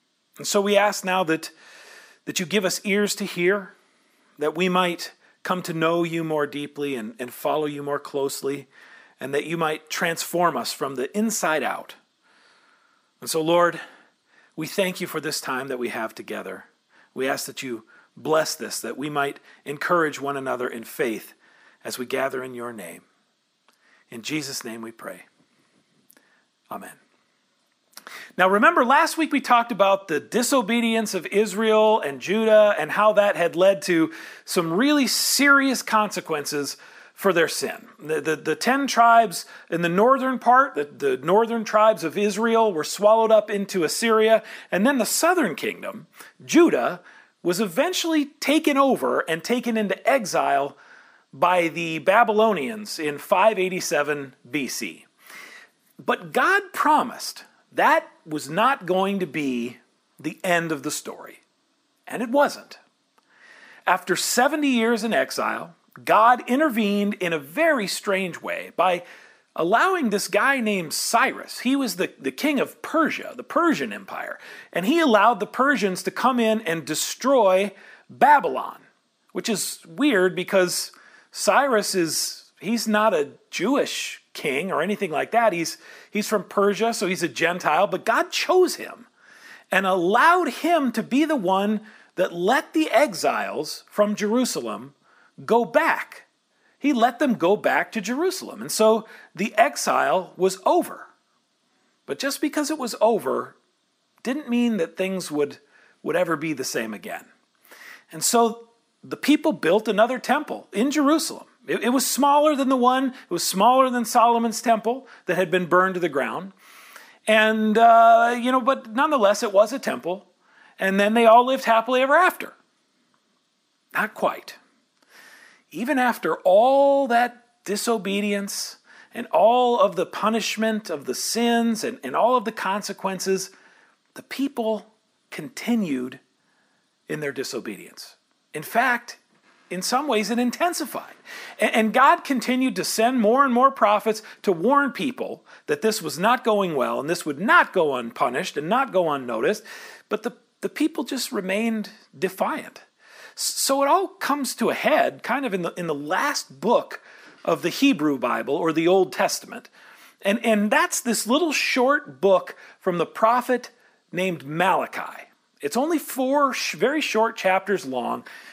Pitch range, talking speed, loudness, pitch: 180-255 Hz, 155 wpm, -22 LUFS, 220 Hz